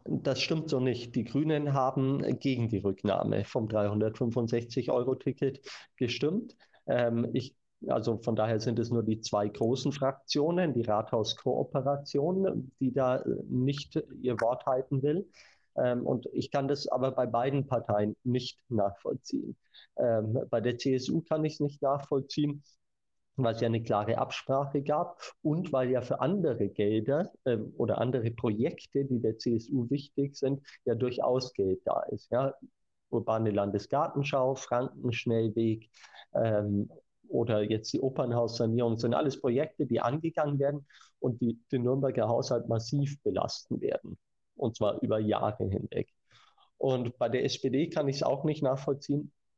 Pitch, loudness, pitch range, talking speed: 125 Hz, -31 LUFS, 115-140 Hz, 145 wpm